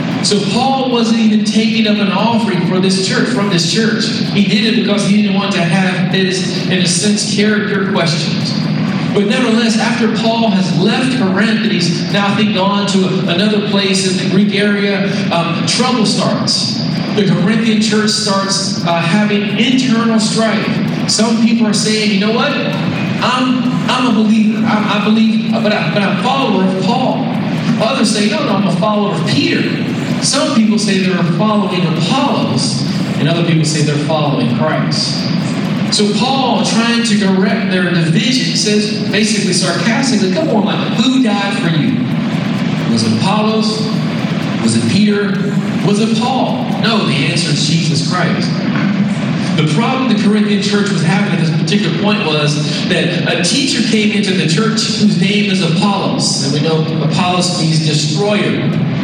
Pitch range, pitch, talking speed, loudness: 185-215 Hz, 205 Hz, 170 wpm, -13 LUFS